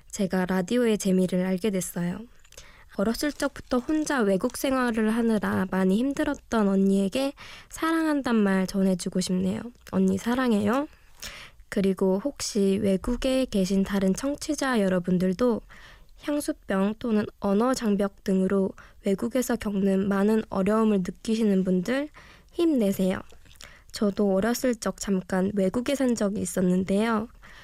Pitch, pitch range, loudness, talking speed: 205 Hz, 195-245 Hz, -26 LUFS, 285 characters per minute